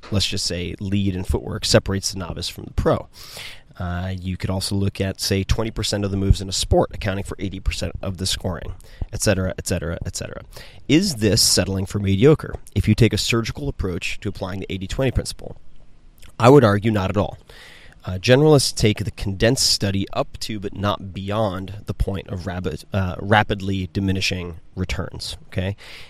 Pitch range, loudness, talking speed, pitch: 95-105 Hz, -21 LUFS, 175 wpm, 100 Hz